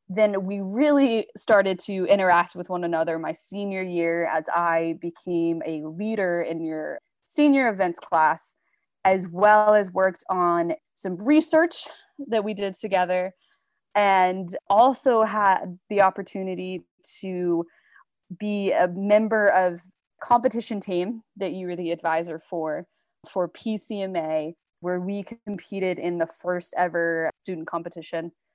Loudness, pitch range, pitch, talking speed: -24 LUFS, 170-210 Hz, 185 Hz, 130 wpm